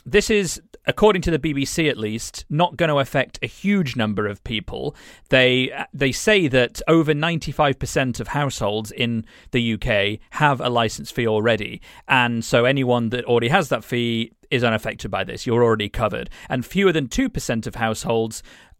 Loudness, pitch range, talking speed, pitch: -21 LUFS, 115-155 Hz, 170 wpm, 125 Hz